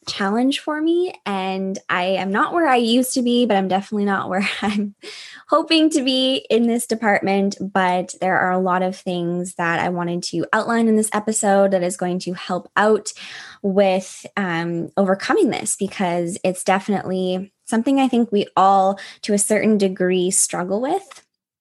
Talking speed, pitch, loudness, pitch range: 175 wpm, 195 Hz, -19 LUFS, 185-225 Hz